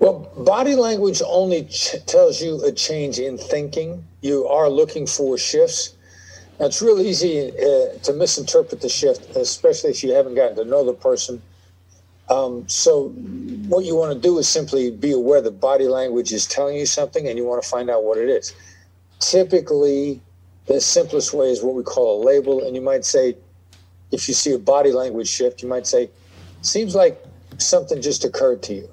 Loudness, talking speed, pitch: -19 LUFS, 190 wpm, 160 Hz